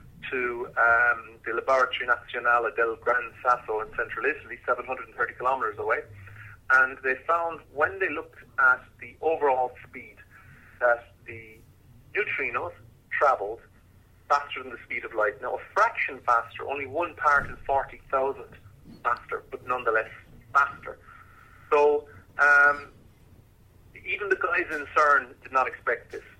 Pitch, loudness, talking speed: 145 Hz, -26 LUFS, 135 wpm